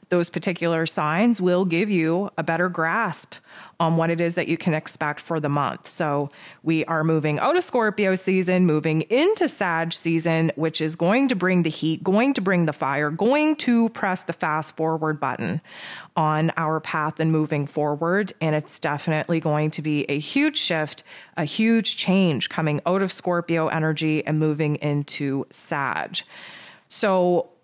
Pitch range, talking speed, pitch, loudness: 155-185 Hz, 170 wpm, 165 Hz, -22 LUFS